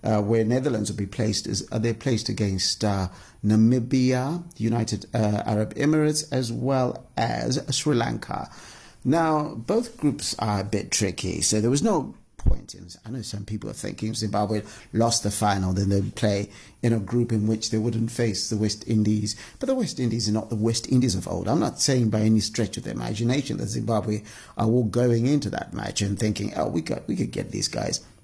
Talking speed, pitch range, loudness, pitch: 210 wpm, 105-125 Hz, -25 LUFS, 110 Hz